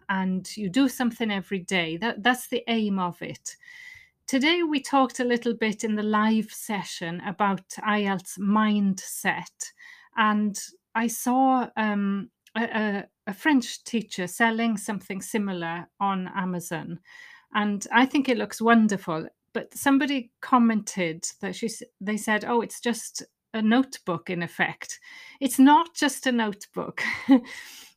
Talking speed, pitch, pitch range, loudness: 135 wpm, 220 Hz, 200-260 Hz, -25 LUFS